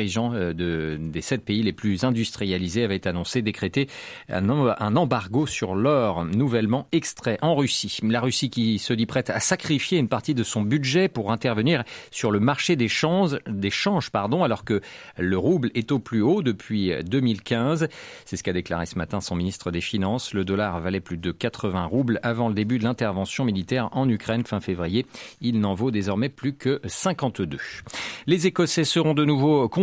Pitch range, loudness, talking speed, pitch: 100-135 Hz, -24 LUFS, 185 wpm, 115 Hz